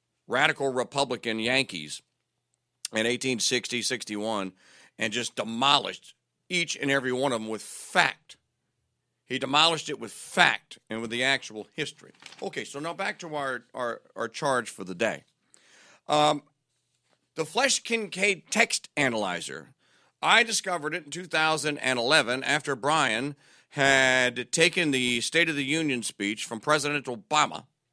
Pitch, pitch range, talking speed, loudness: 140 Hz, 120-155 Hz, 135 wpm, -26 LUFS